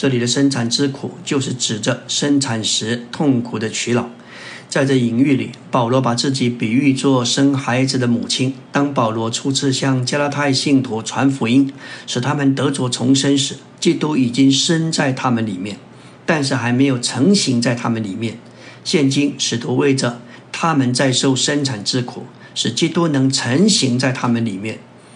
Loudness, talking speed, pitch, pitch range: -17 LUFS, 255 characters per minute, 130 Hz, 120-140 Hz